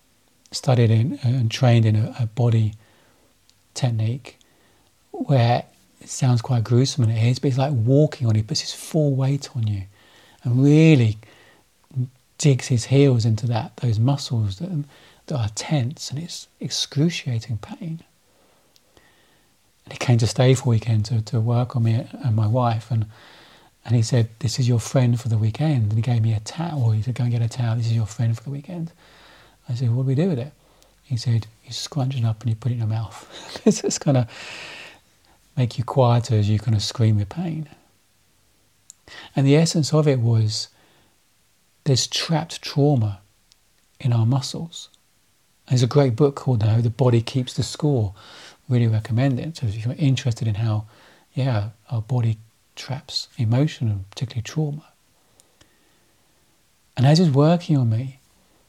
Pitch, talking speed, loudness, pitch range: 120 Hz, 180 wpm, -21 LUFS, 110-140 Hz